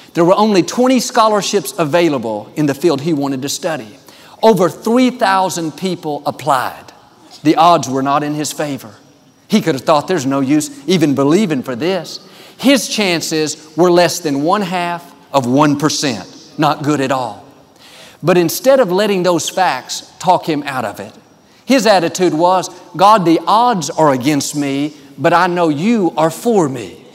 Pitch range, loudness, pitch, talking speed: 145-185 Hz, -14 LUFS, 165 Hz, 165 wpm